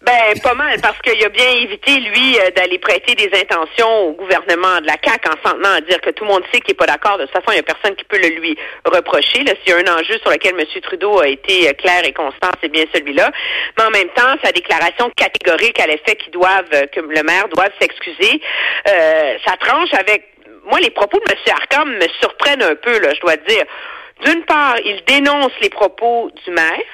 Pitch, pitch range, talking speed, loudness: 210 Hz, 180-275 Hz, 230 wpm, -13 LUFS